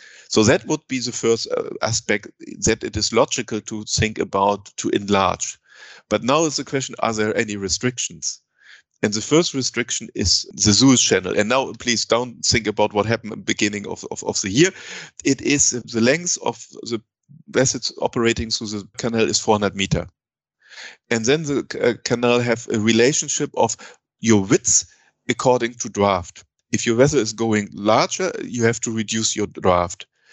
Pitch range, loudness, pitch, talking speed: 105-125 Hz, -20 LUFS, 115 Hz, 180 wpm